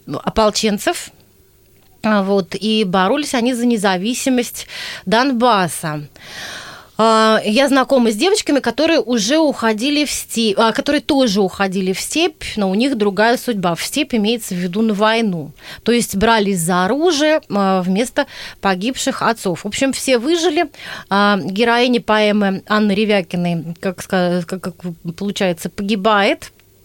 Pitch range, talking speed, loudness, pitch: 195-250 Hz, 120 wpm, -16 LUFS, 215 Hz